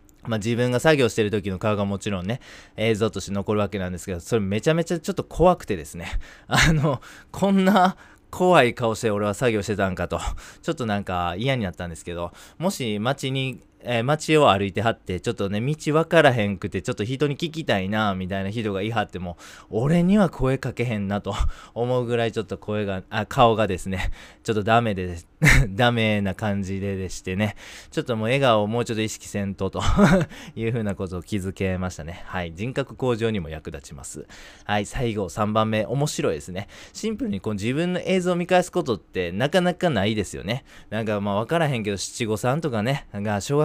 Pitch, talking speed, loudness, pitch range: 110 Hz, 405 characters per minute, -23 LUFS, 100-135 Hz